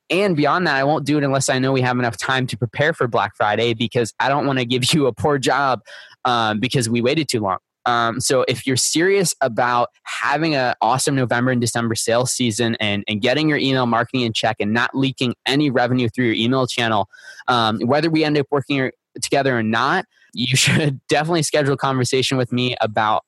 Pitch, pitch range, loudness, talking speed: 125 Hz, 120-140 Hz, -19 LUFS, 215 wpm